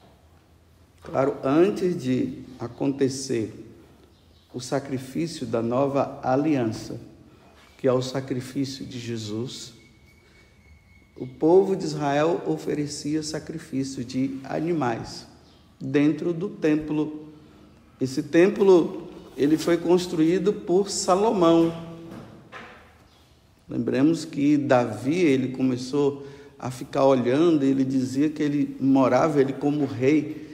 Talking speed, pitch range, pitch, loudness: 95 wpm, 125-155 Hz, 140 Hz, -24 LUFS